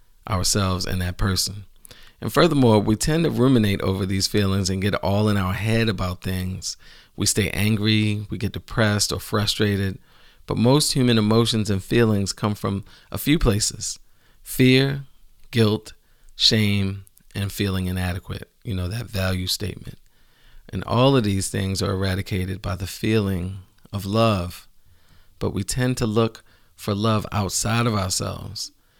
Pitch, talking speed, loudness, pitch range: 100 Hz, 150 wpm, -22 LUFS, 95-110 Hz